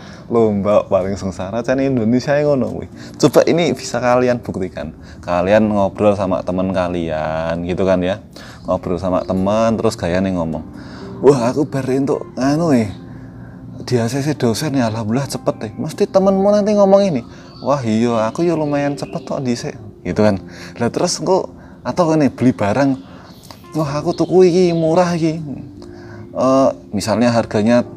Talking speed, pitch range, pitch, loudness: 150 wpm, 95-140 Hz, 115 Hz, -17 LUFS